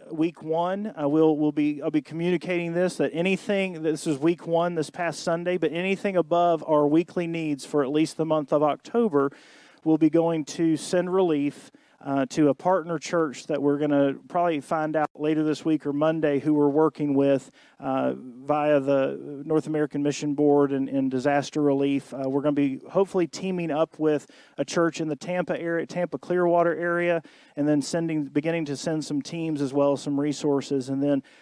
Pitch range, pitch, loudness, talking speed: 145-170 Hz, 155 Hz, -25 LUFS, 195 wpm